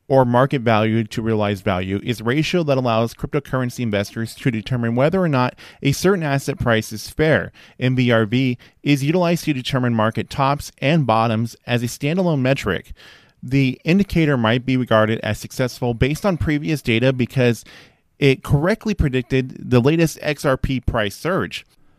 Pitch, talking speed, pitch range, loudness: 130 Hz, 155 wpm, 115-145 Hz, -19 LUFS